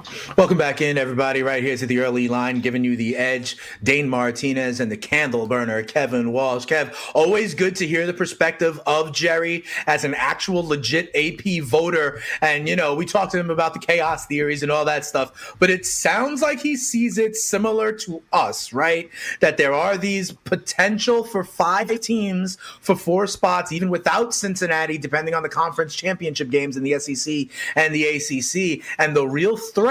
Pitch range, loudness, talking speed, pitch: 140-185 Hz, -21 LUFS, 185 wpm, 160 Hz